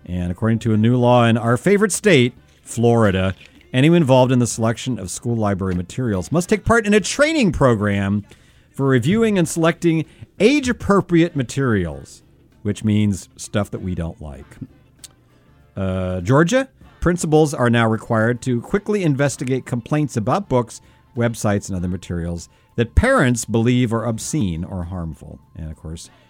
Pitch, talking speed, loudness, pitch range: 120 Hz, 155 wpm, -18 LUFS, 95-145 Hz